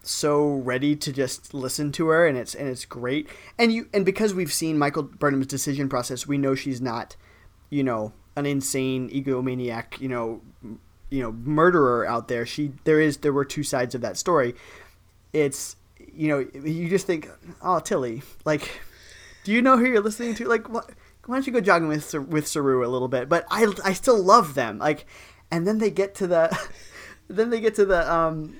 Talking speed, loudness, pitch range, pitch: 200 wpm, -24 LUFS, 130-180 Hz, 150 Hz